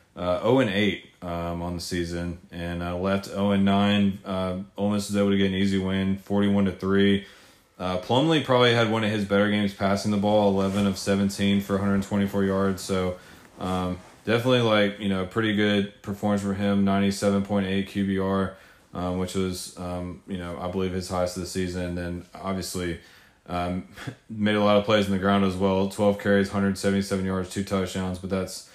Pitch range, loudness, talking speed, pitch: 90-100 Hz, -25 LUFS, 210 wpm, 100 Hz